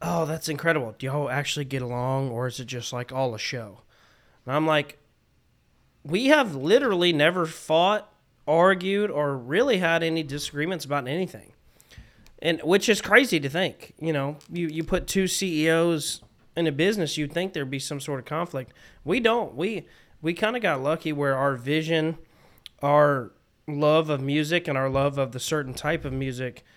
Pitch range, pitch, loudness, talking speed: 140-170 Hz, 155 Hz, -25 LUFS, 175 wpm